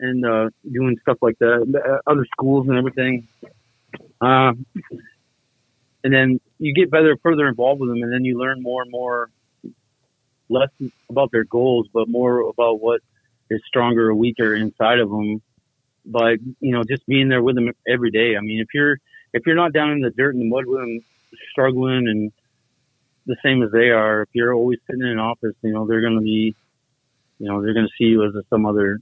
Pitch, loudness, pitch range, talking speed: 120 Hz, -19 LUFS, 115-130 Hz, 205 wpm